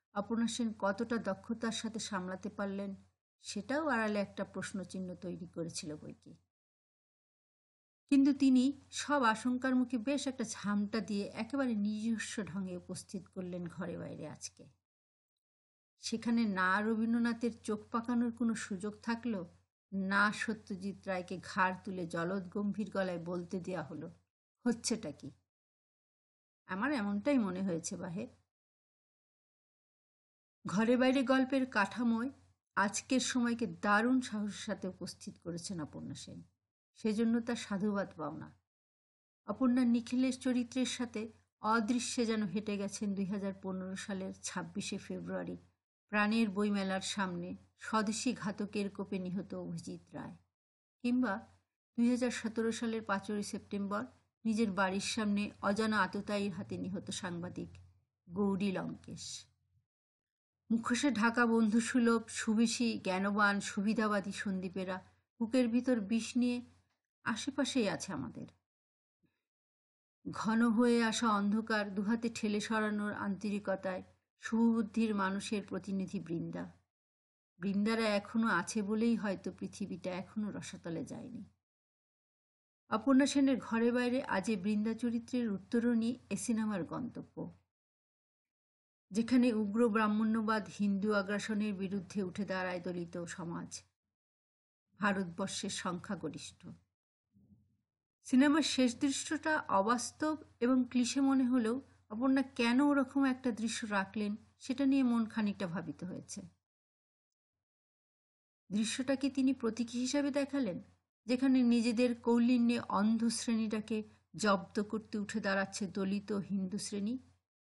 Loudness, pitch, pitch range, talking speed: -35 LUFS, 210 Hz, 190-235 Hz, 95 wpm